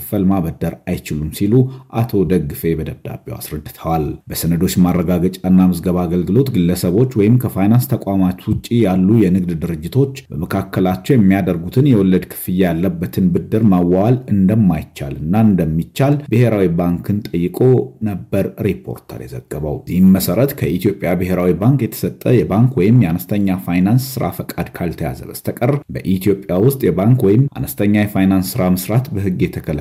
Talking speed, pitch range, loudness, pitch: 120 wpm, 90-120 Hz, -16 LUFS, 95 Hz